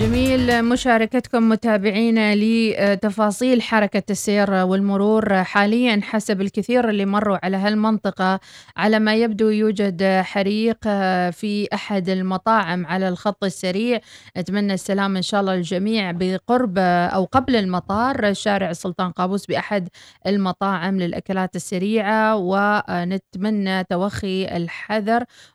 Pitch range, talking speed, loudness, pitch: 190-220 Hz, 105 wpm, -20 LUFS, 200 Hz